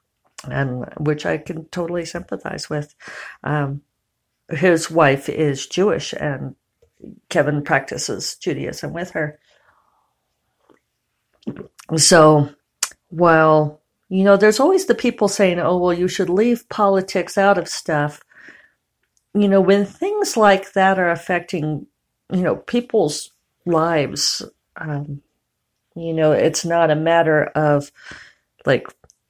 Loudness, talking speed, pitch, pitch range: -18 LUFS, 115 wpm, 170 Hz, 150-190 Hz